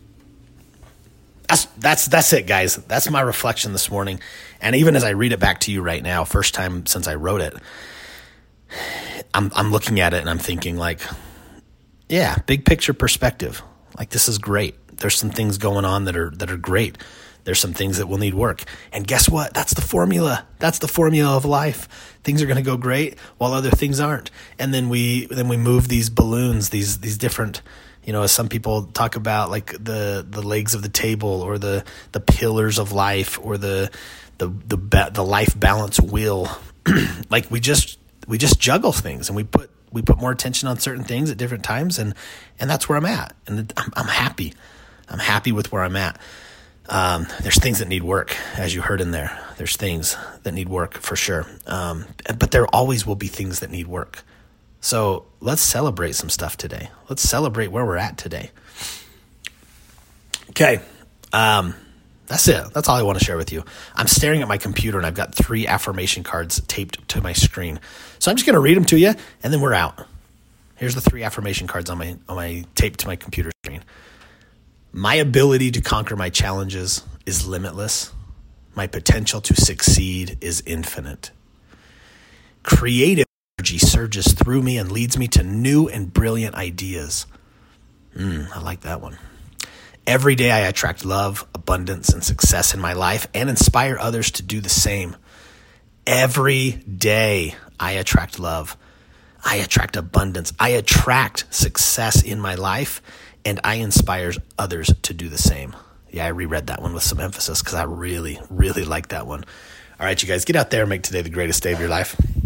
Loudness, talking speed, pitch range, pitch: -19 LUFS, 185 wpm, 90-115 Hz, 100 Hz